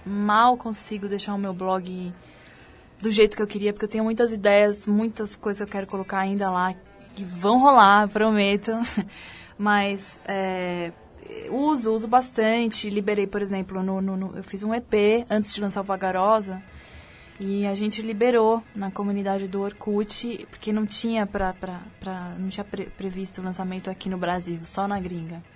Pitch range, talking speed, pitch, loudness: 190-215 Hz, 175 wpm, 200 Hz, -24 LUFS